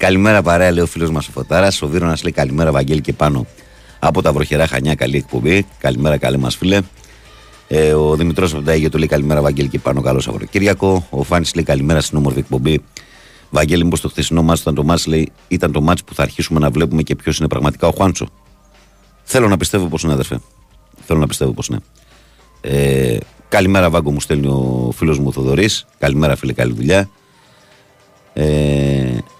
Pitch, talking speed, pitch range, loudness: 75 Hz, 190 wpm, 70-85 Hz, -15 LUFS